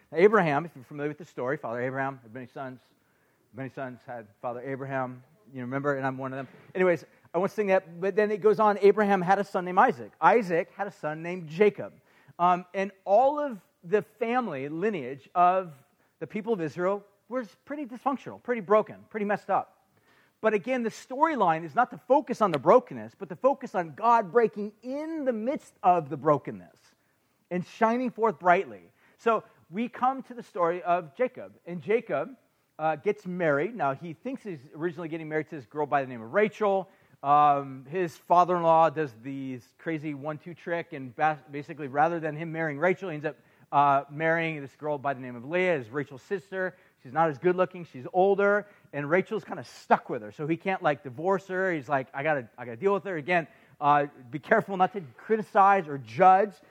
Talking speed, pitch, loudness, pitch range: 200 wpm, 175 Hz, -27 LUFS, 145-205 Hz